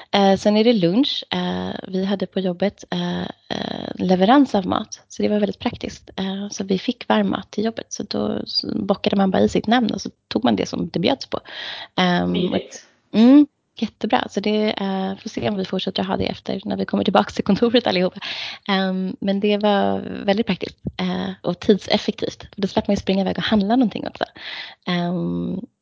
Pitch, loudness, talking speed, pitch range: 200 Hz, -21 LUFS, 175 wpm, 190-225 Hz